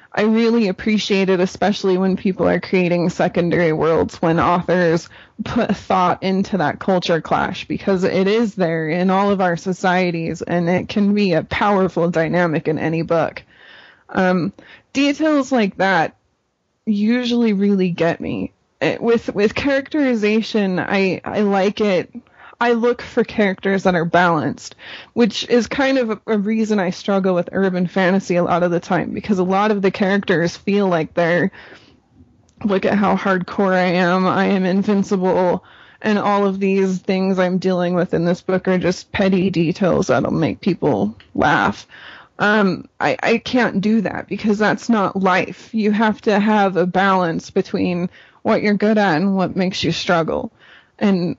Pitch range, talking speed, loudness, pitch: 175-210 Hz, 165 wpm, -18 LUFS, 190 Hz